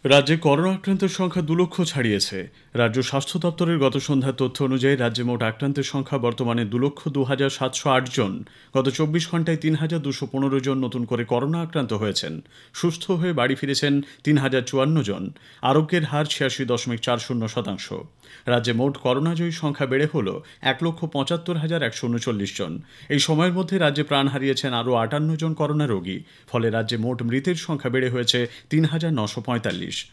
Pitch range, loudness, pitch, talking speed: 120-155 Hz, -23 LUFS, 135 Hz, 180 wpm